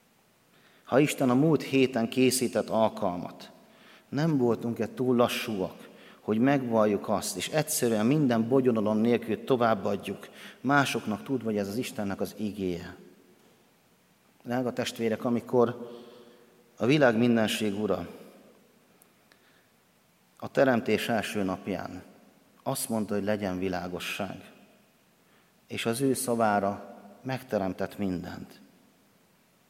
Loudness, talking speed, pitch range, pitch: -28 LUFS, 100 wpm, 105-125 Hz, 115 Hz